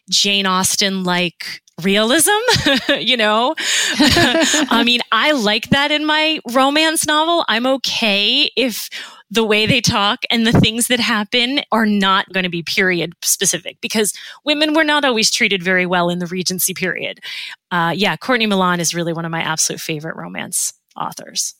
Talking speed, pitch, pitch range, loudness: 165 wpm, 215 Hz, 185-260 Hz, -15 LUFS